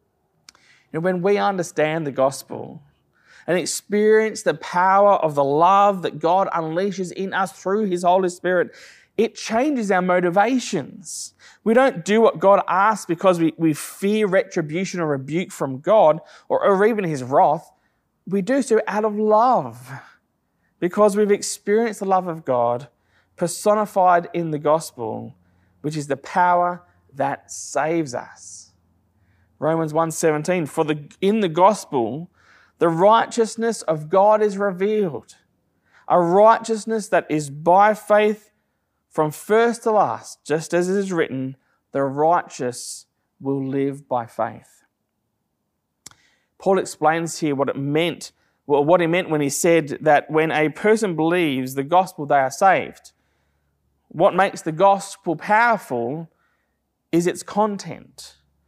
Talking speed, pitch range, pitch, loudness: 140 wpm, 140-200 Hz, 170 Hz, -20 LUFS